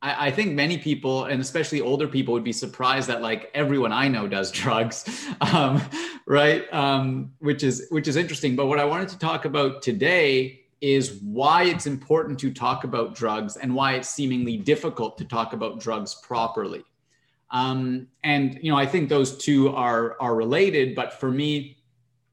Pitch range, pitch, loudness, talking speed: 125-145 Hz, 135 Hz, -24 LUFS, 175 wpm